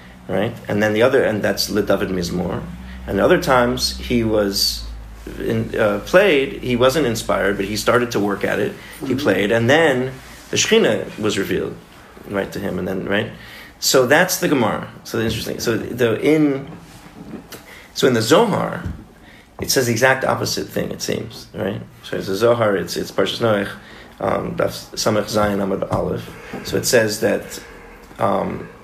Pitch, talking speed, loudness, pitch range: 115 Hz, 165 wpm, -19 LUFS, 100-130 Hz